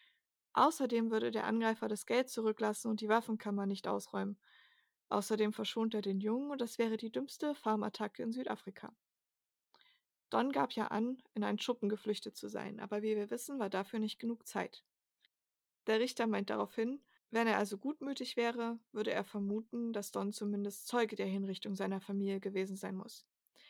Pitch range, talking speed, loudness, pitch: 205-235 Hz, 170 wpm, -37 LUFS, 215 Hz